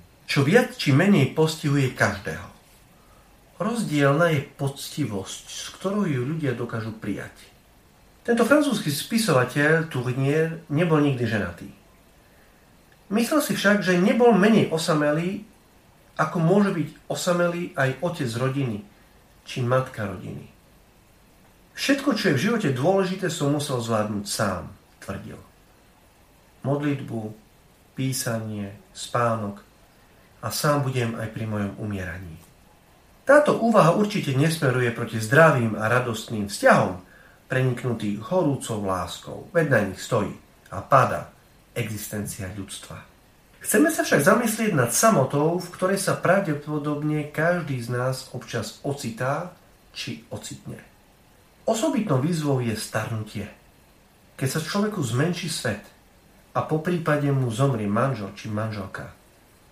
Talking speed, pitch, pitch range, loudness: 115 wpm, 140 Hz, 110-175 Hz, -23 LUFS